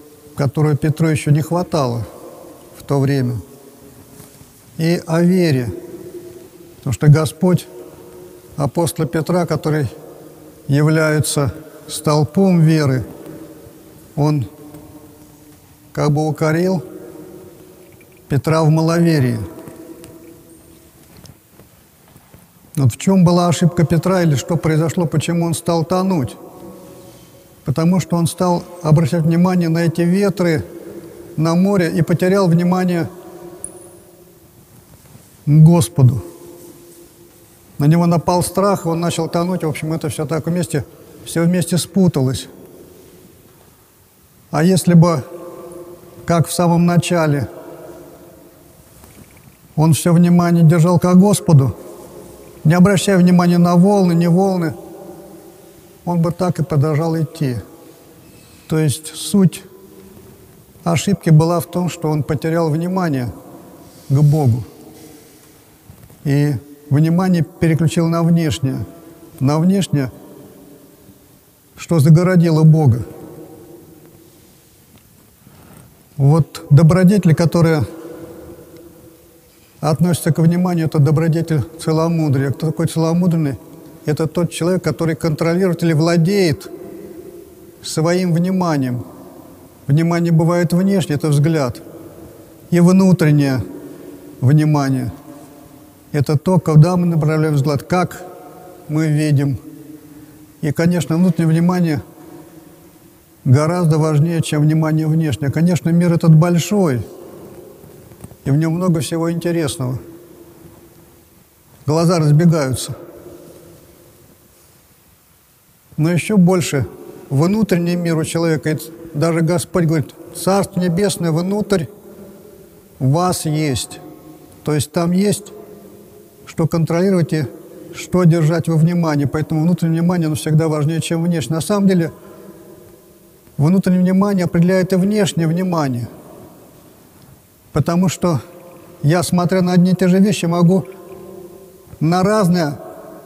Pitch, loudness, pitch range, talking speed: 165 Hz, -16 LUFS, 150-175 Hz, 100 wpm